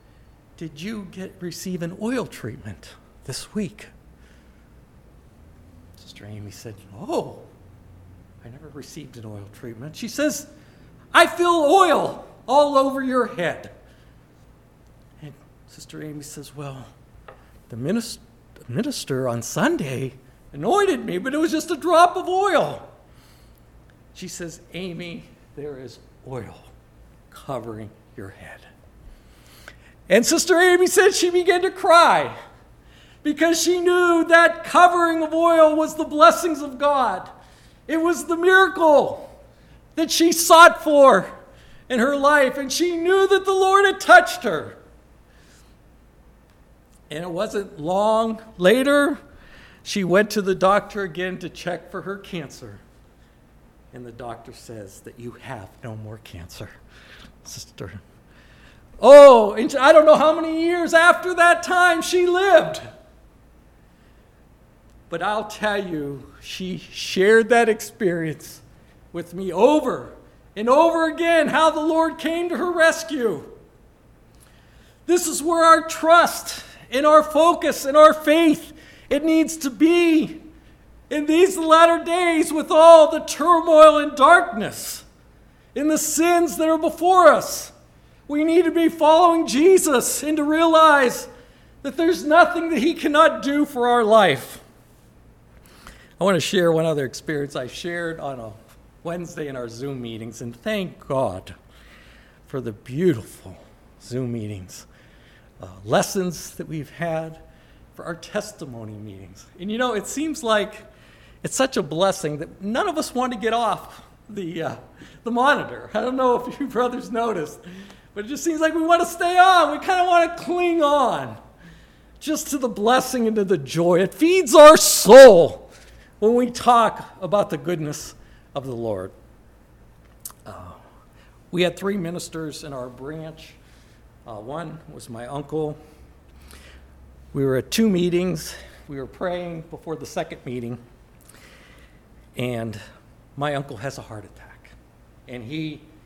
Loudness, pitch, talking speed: -17 LUFS, 210 Hz, 140 wpm